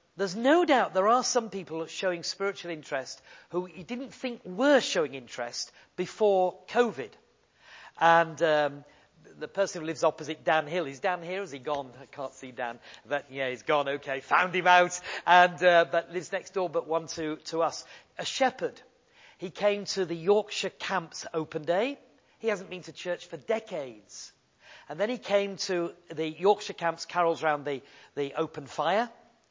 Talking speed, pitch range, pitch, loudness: 180 wpm, 155-195 Hz, 175 Hz, -28 LUFS